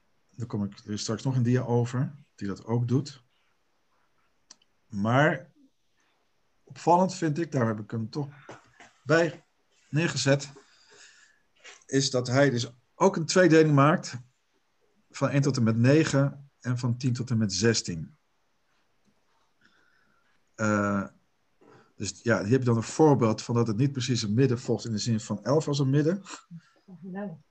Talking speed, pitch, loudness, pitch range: 155 wpm, 130 Hz, -26 LUFS, 115-150 Hz